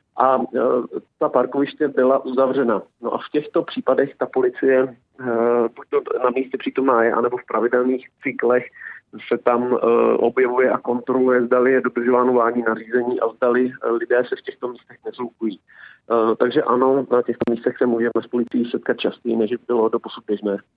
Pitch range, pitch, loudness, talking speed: 120-130 Hz, 125 Hz, -20 LUFS, 160 wpm